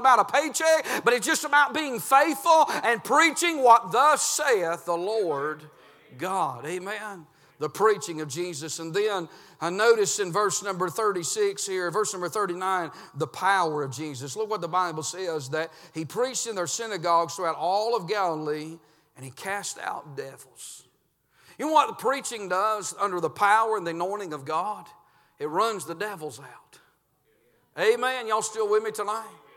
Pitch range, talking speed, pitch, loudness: 165-230 Hz, 170 wpm, 200 Hz, -25 LUFS